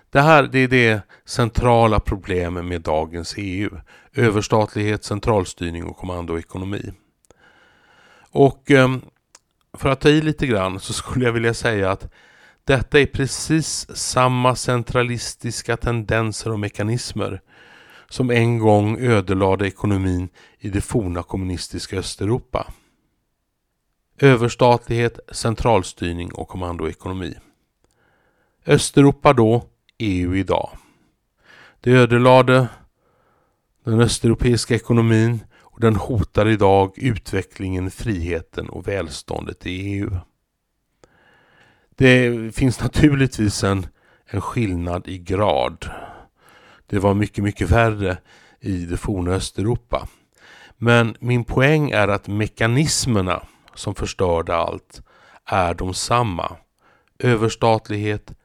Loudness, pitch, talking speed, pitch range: -19 LUFS, 110 Hz, 100 wpm, 95-120 Hz